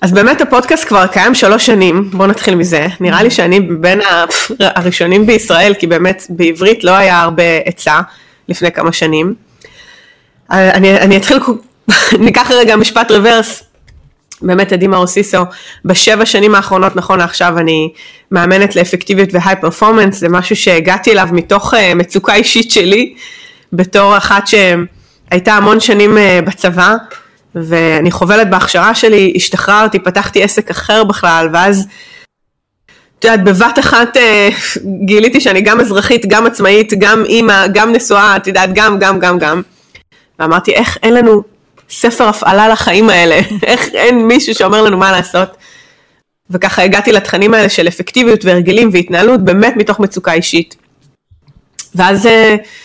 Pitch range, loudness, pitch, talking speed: 180-220 Hz, -8 LUFS, 200 Hz, 135 wpm